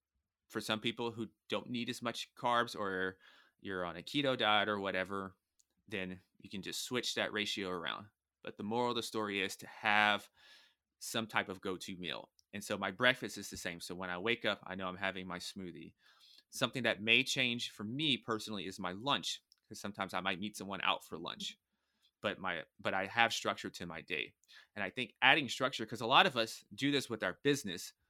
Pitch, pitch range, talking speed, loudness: 105 Hz, 95-115 Hz, 215 wpm, -36 LUFS